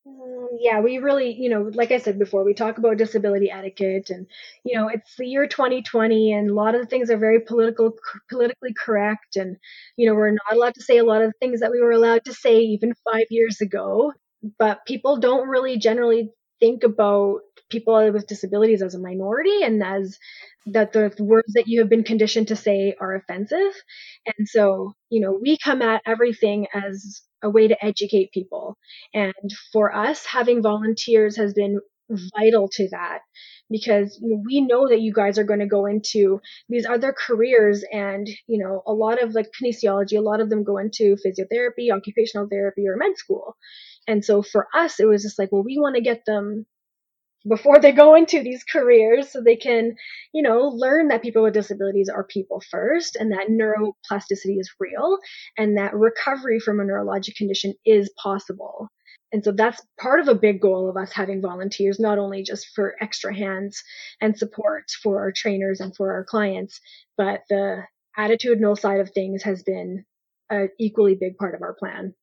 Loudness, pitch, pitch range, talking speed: -20 LUFS, 215 Hz, 200-235 Hz, 190 wpm